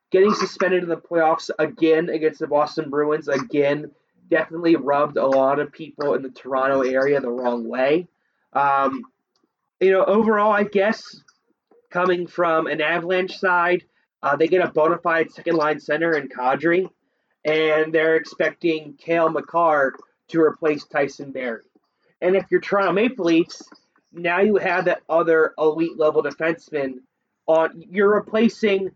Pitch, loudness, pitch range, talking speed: 160 Hz, -21 LUFS, 150-180 Hz, 150 wpm